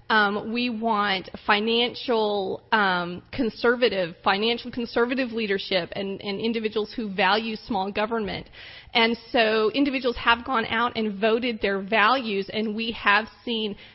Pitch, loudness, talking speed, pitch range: 220 Hz, -24 LUFS, 125 wpm, 205-235 Hz